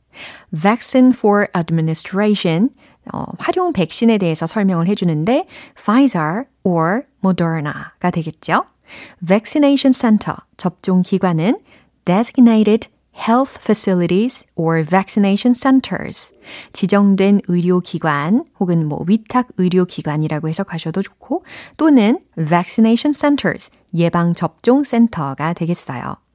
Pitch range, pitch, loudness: 170-245 Hz, 200 Hz, -16 LUFS